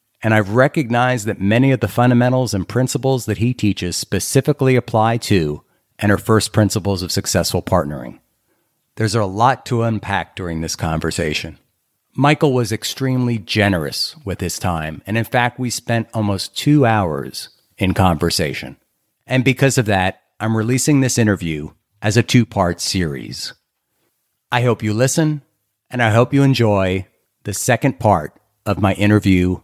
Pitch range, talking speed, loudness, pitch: 95-125 Hz, 155 wpm, -17 LUFS, 110 Hz